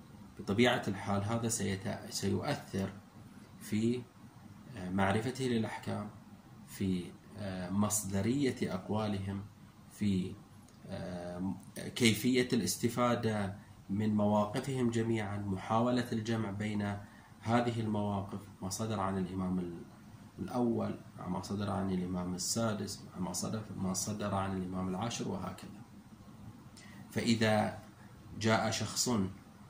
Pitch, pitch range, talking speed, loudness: 105 Hz, 100-110 Hz, 85 wpm, -35 LUFS